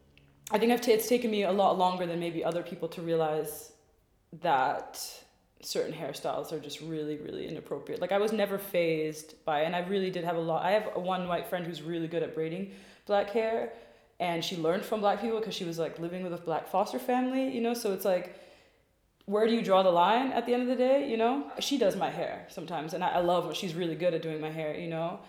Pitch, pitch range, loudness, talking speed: 180 Hz, 165-215 Hz, -30 LUFS, 235 wpm